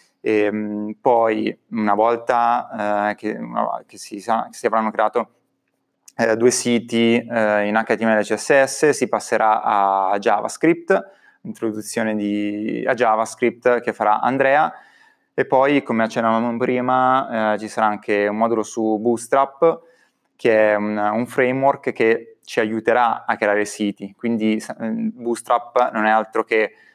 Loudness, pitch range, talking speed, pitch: -19 LUFS, 105-125 Hz, 135 wpm, 115 Hz